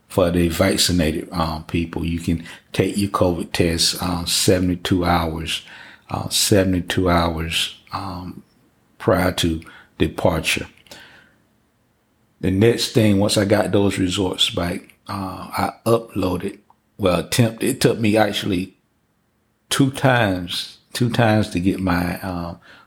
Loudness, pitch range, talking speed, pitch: -20 LUFS, 85-100 Hz, 125 wpm, 95 Hz